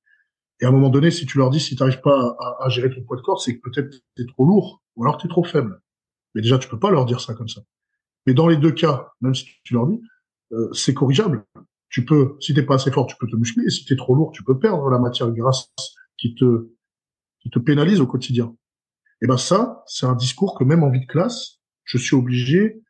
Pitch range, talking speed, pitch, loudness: 125-165 Hz, 265 wpm, 130 Hz, -19 LUFS